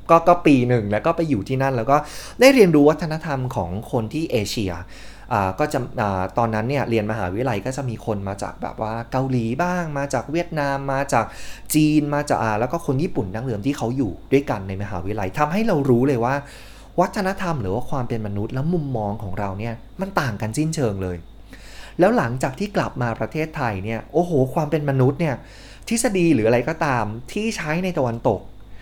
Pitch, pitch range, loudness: 130 Hz, 110-150 Hz, -21 LUFS